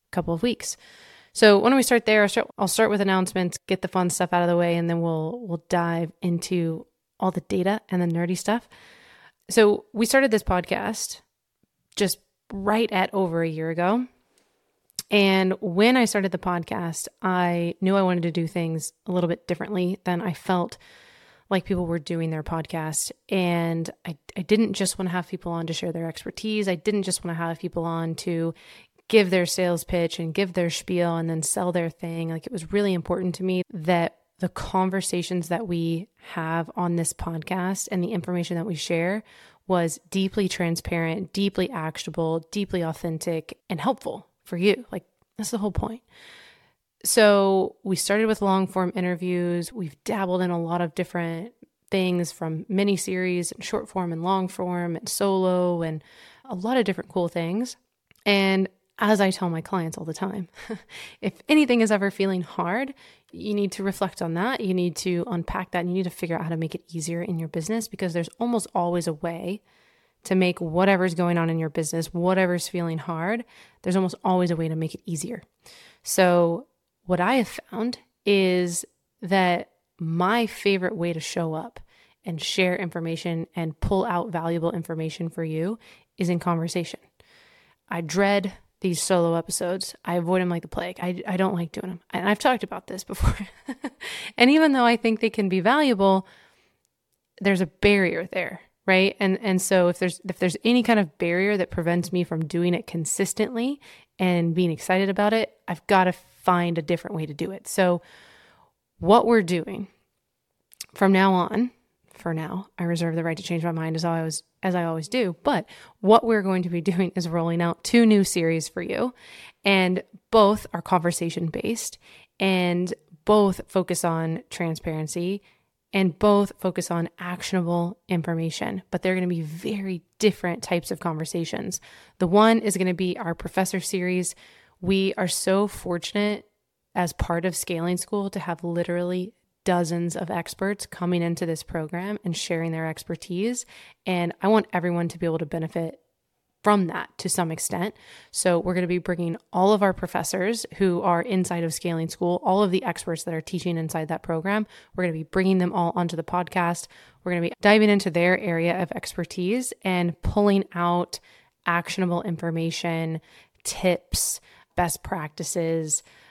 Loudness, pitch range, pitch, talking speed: -25 LUFS, 170-195 Hz, 180 Hz, 185 wpm